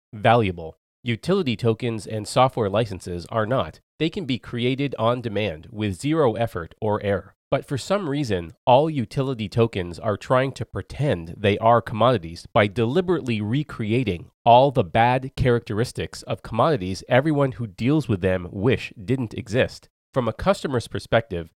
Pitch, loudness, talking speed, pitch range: 115 Hz, -23 LUFS, 150 wpm, 100-130 Hz